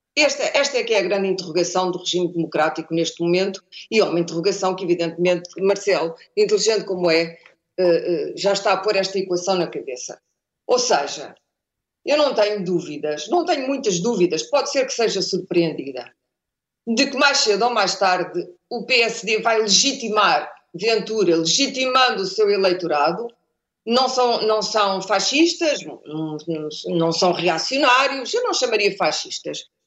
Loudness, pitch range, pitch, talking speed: -20 LUFS, 175-250 Hz, 195 Hz, 150 wpm